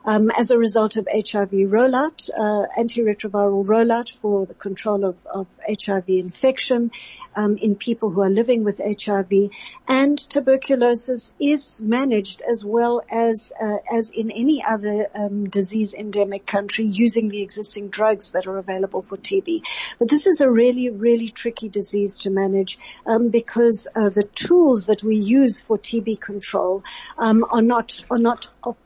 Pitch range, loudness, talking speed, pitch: 205-240 Hz, -20 LUFS, 160 wpm, 220 Hz